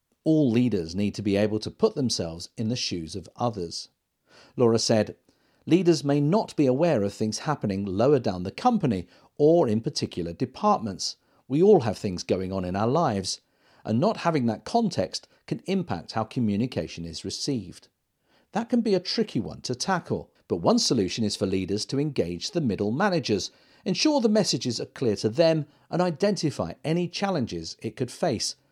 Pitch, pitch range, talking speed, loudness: 120 Hz, 100-170 Hz, 180 wpm, -26 LUFS